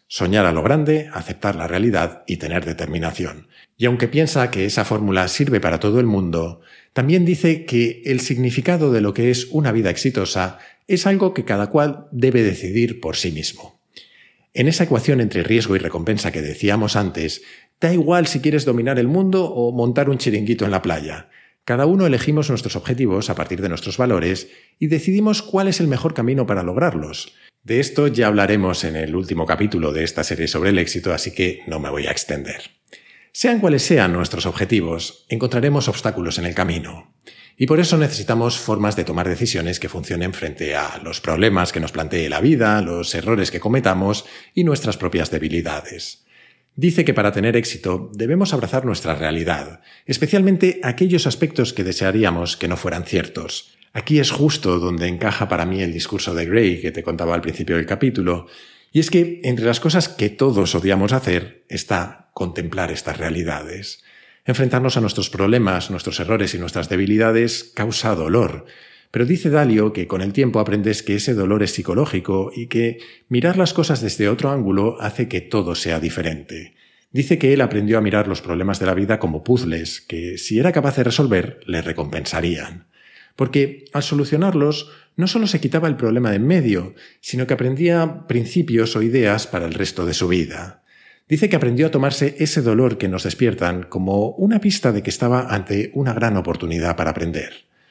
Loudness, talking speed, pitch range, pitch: -19 LUFS, 185 wpm, 90-135 Hz, 110 Hz